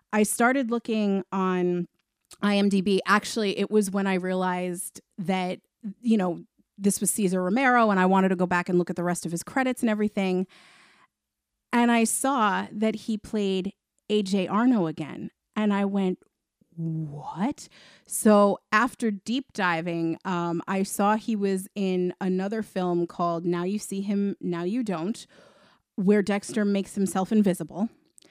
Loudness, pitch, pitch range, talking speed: -26 LUFS, 195 Hz, 185-215 Hz, 155 wpm